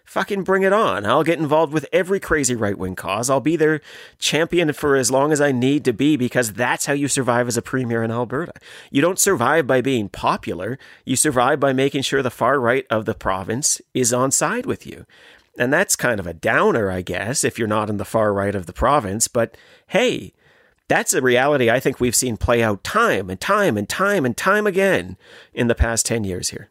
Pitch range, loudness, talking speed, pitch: 115-150 Hz, -19 LUFS, 225 wpm, 130 Hz